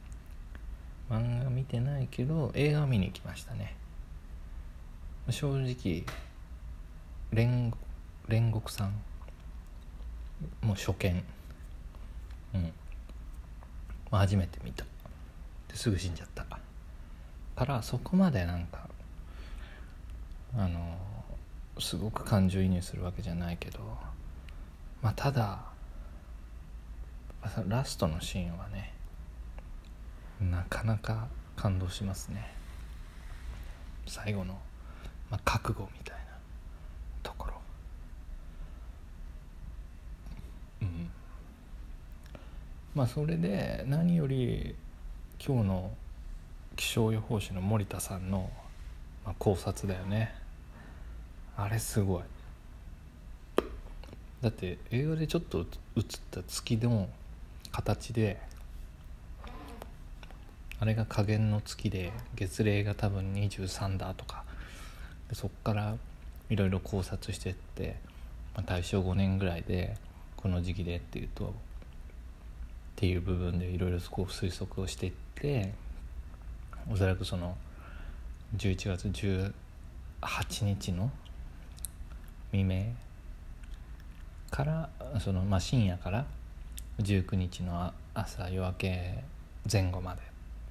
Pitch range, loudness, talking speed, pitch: 75-100 Hz, -34 LUFS, 175 characters per minute, 85 Hz